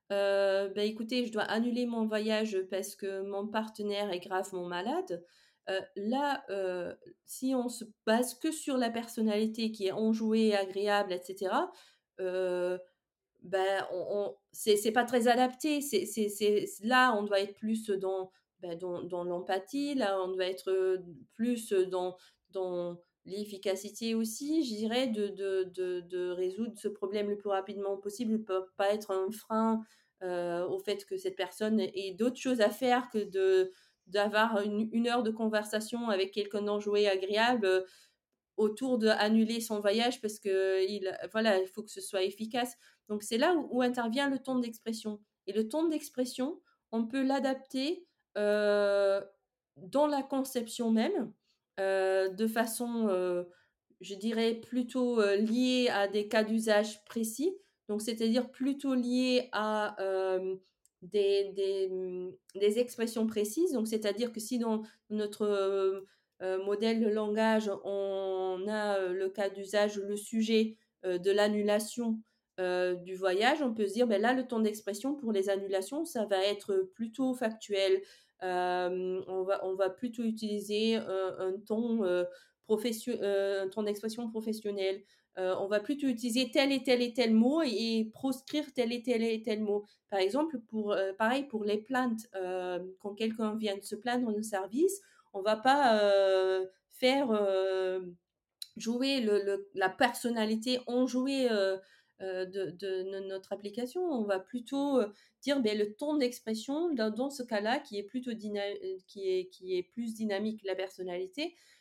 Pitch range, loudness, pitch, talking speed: 195-235 Hz, -32 LUFS, 210 Hz, 160 wpm